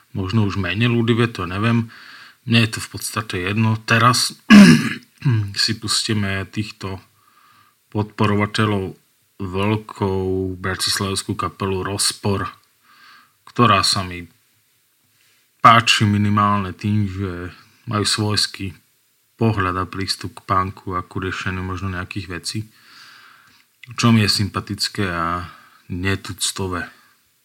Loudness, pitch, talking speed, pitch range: -19 LUFS, 100 Hz, 100 wpm, 95-110 Hz